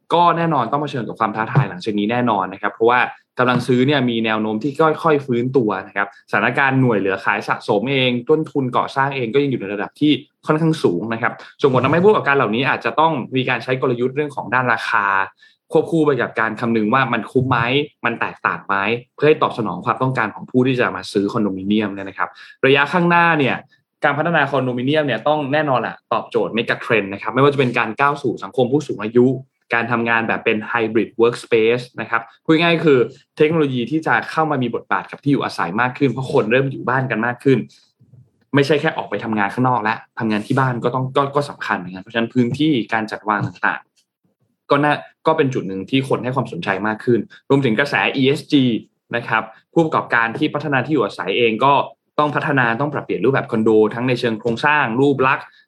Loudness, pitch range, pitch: -18 LUFS, 115-145 Hz, 125 Hz